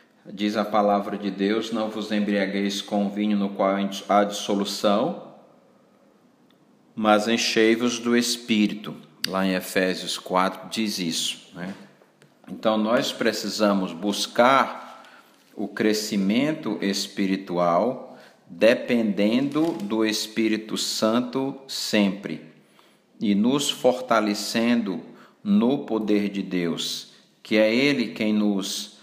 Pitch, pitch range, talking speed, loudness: 105 Hz, 100-110 Hz, 105 wpm, -23 LUFS